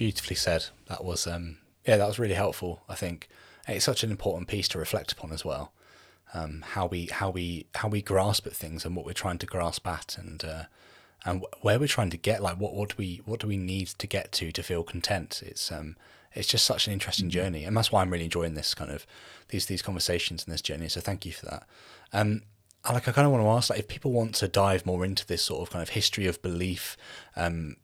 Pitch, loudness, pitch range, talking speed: 95 Hz, -29 LUFS, 85-105 Hz, 250 wpm